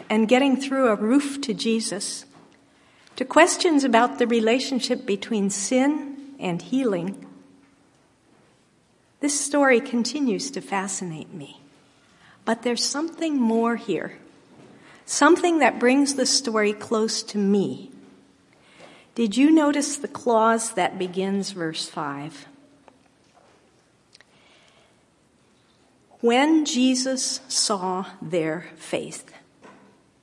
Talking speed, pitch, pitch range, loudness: 95 wpm, 235 Hz, 200-270 Hz, -22 LUFS